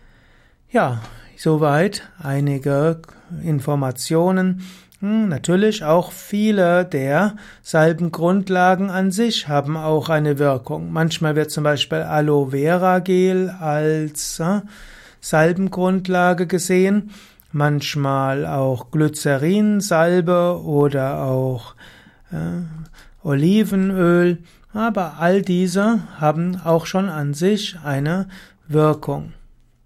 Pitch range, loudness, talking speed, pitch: 150-185 Hz, -19 LUFS, 90 wpm, 165 Hz